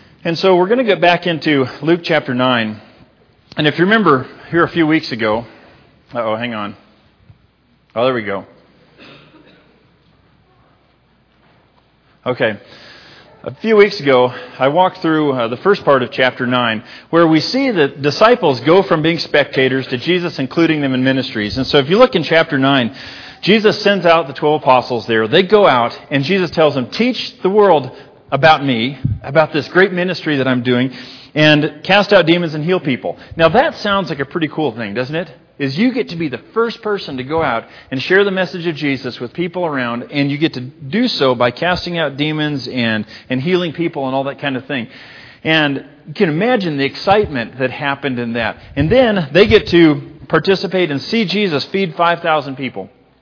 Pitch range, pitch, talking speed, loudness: 130-180 Hz, 150 Hz, 195 wpm, -15 LUFS